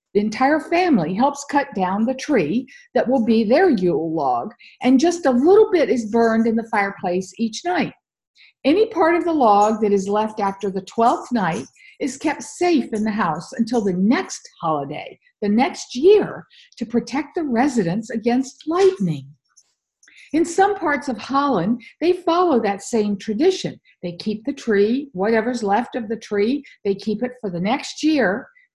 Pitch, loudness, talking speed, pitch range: 240 Hz, -20 LUFS, 175 wpm, 210-285 Hz